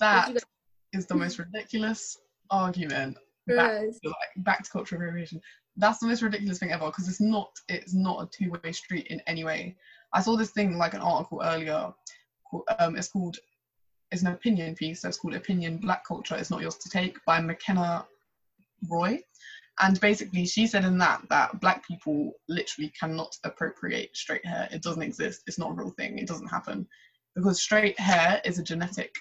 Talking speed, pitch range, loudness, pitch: 185 wpm, 170-210 Hz, -28 LUFS, 185 Hz